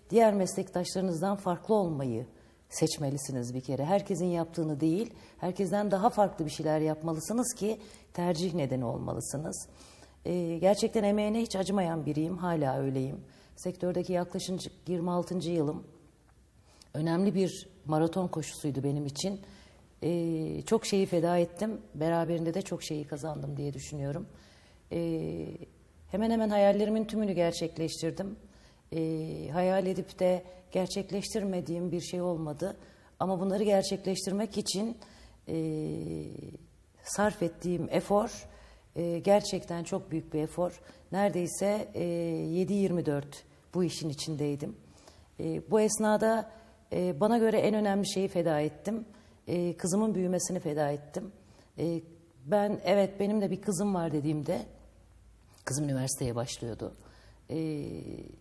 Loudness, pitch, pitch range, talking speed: -31 LUFS, 175 Hz, 150-195 Hz, 115 wpm